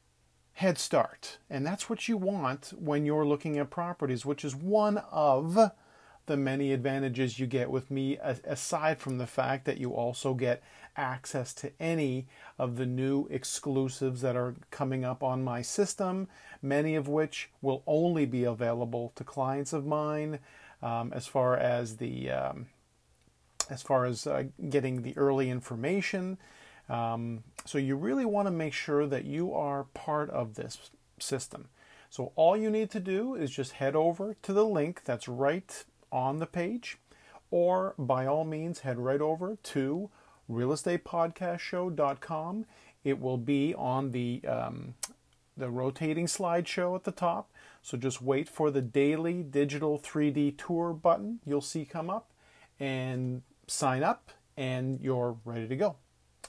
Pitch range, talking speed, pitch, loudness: 130-165 Hz, 155 wpm, 140 Hz, -32 LUFS